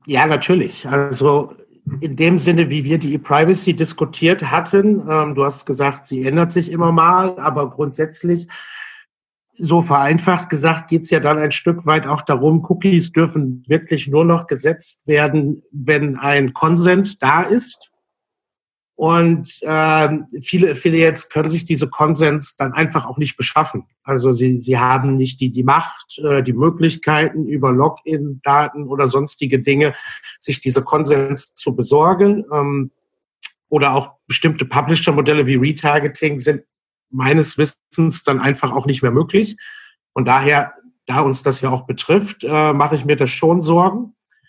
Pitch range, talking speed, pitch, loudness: 140-165 Hz, 150 wpm, 150 Hz, -16 LUFS